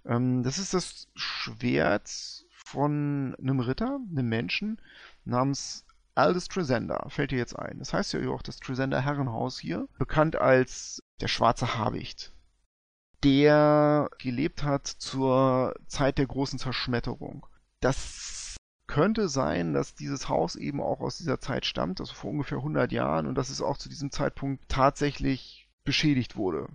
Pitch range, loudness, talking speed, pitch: 125-145 Hz, -28 LUFS, 145 wpm, 135 Hz